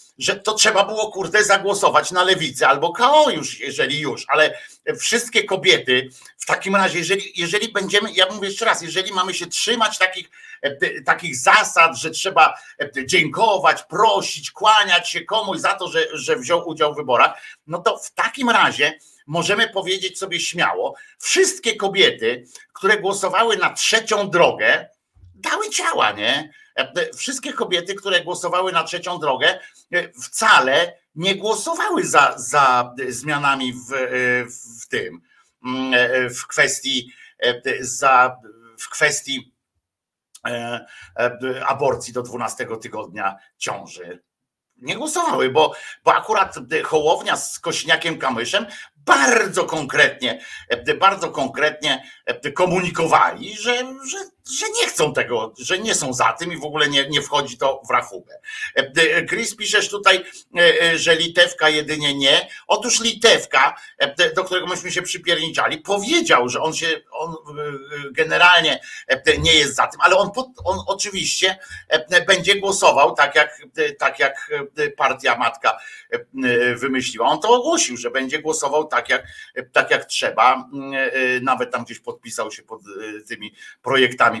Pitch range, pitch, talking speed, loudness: 150-240 Hz, 185 Hz, 130 wpm, -18 LUFS